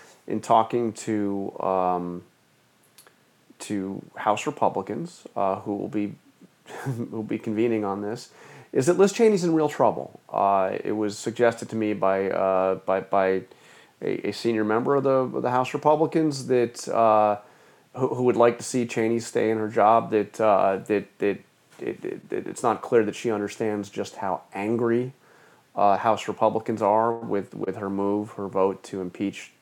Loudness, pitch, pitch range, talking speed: -25 LUFS, 110 Hz, 100-120 Hz, 170 wpm